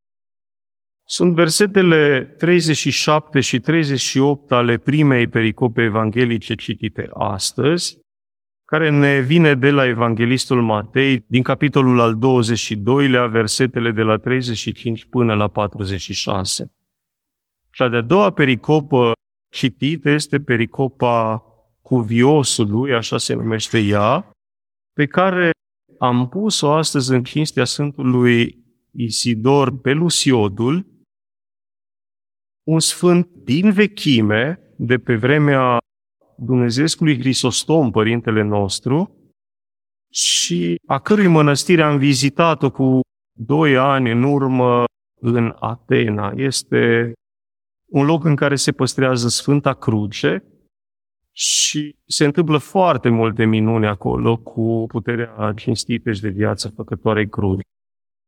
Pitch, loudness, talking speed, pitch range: 125 Hz, -17 LUFS, 100 wpm, 110-145 Hz